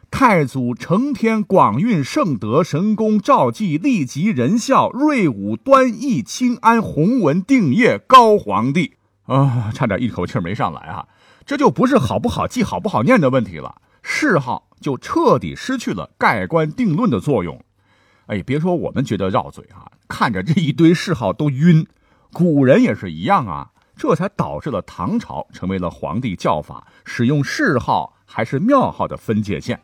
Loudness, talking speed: -17 LUFS, 245 characters per minute